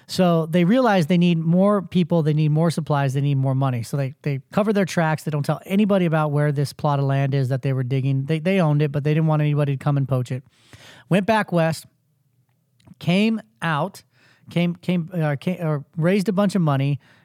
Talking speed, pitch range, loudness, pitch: 230 wpm, 140-175 Hz, -21 LUFS, 155 Hz